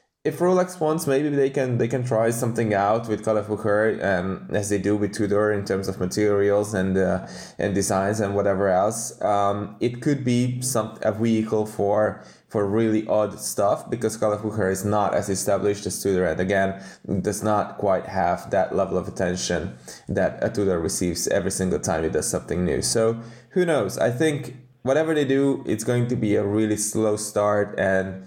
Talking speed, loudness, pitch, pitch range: 190 wpm, -23 LUFS, 105 Hz, 100-120 Hz